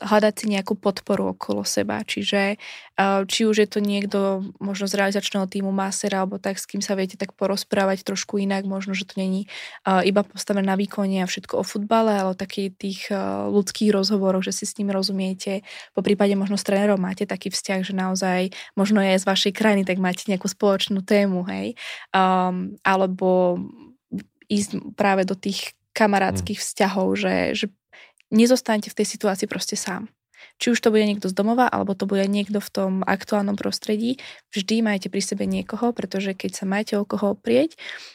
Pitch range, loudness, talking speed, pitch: 190-210 Hz, -23 LUFS, 180 wpm, 200 Hz